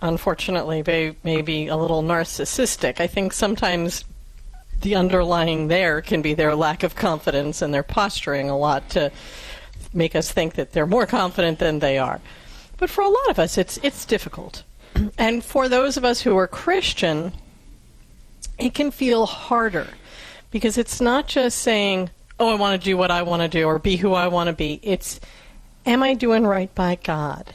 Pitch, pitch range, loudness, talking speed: 180 Hz, 160-230 Hz, -21 LUFS, 185 wpm